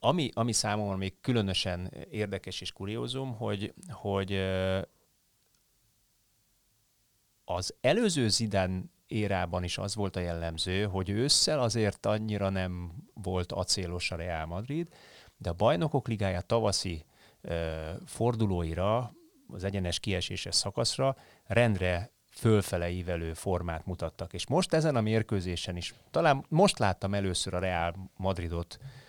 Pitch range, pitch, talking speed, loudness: 90-115 Hz, 100 Hz, 120 wpm, -31 LUFS